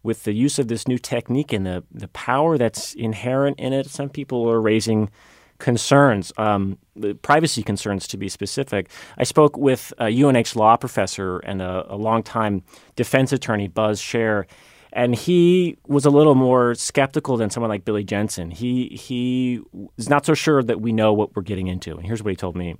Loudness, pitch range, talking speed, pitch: -20 LUFS, 105-135 Hz, 190 wpm, 115 Hz